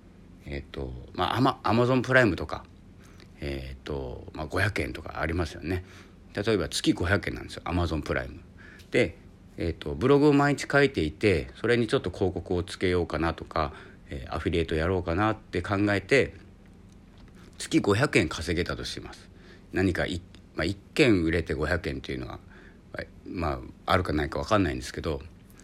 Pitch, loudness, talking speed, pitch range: 90 Hz, -27 LUFS, 335 characters per minute, 80-100 Hz